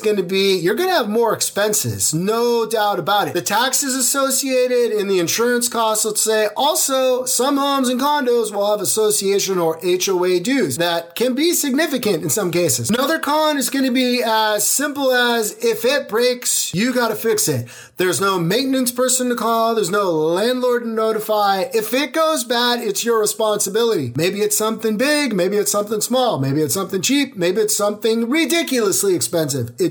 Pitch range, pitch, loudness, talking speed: 195-255 Hz, 225 Hz, -17 LUFS, 185 wpm